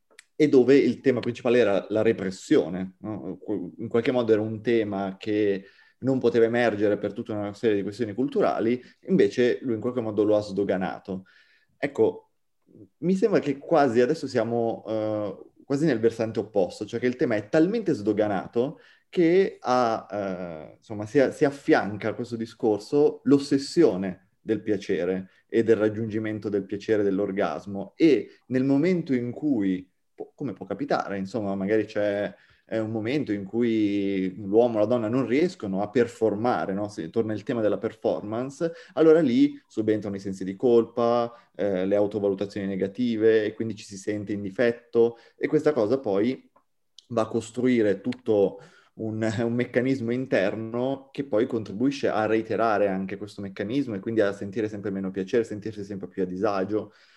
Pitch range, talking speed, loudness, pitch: 100-125 Hz, 160 wpm, -25 LUFS, 110 Hz